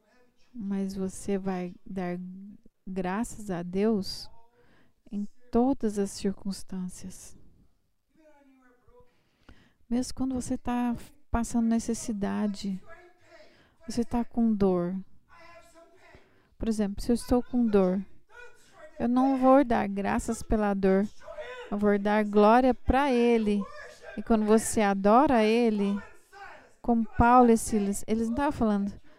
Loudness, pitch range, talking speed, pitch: -27 LUFS, 200-250 Hz, 110 wpm, 230 Hz